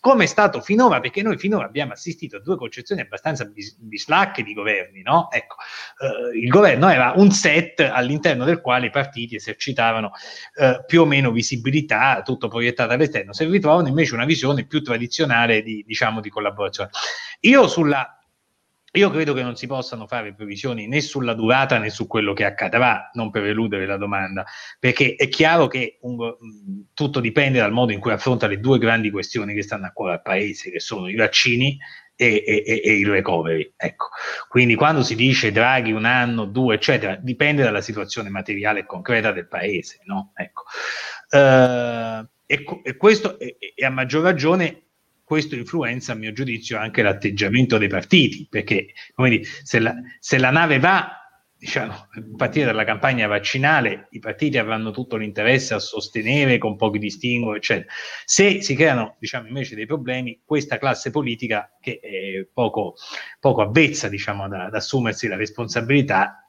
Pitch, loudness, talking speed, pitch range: 120 Hz, -19 LUFS, 170 wpm, 110-145 Hz